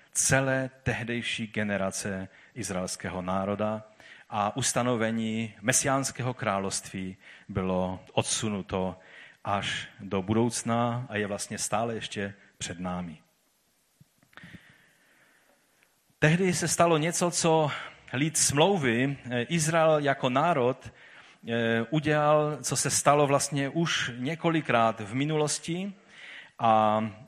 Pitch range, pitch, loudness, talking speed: 105-145 Hz, 120 Hz, -27 LUFS, 90 wpm